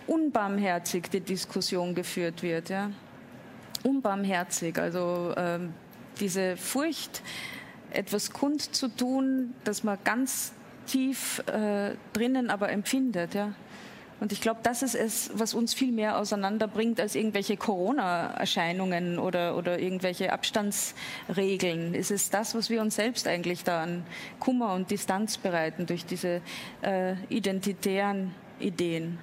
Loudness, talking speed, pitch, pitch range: -30 LUFS, 125 wpm, 200 Hz, 180-230 Hz